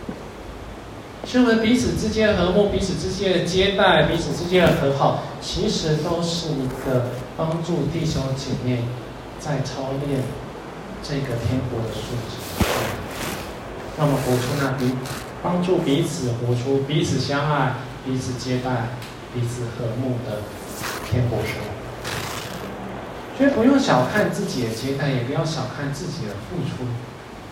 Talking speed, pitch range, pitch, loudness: 205 characters per minute, 125-165 Hz, 135 Hz, -23 LUFS